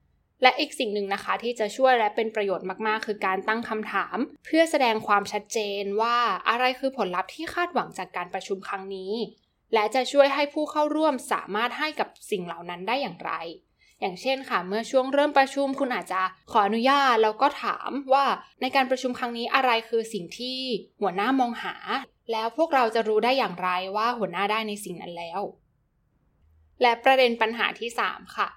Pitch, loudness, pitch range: 230 Hz, -25 LUFS, 205-265 Hz